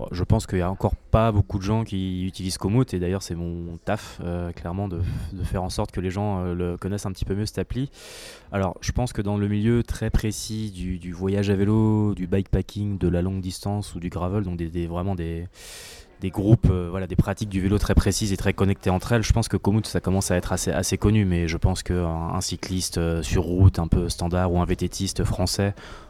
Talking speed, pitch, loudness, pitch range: 245 wpm, 95 Hz, -25 LUFS, 90-105 Hz